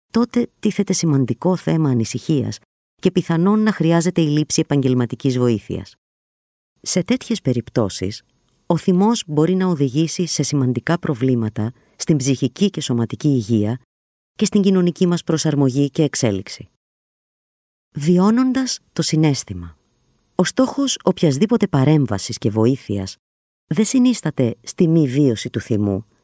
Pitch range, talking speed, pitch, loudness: 115-180 Hz, 120 wpm, 145 Hz, -18 LUFS